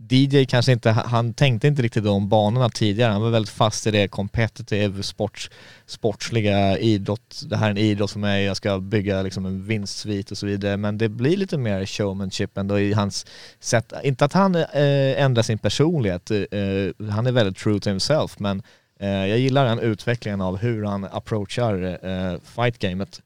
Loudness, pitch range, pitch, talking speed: -22 LUFS, 100-120 Hz, 105 Hz, 190 wpm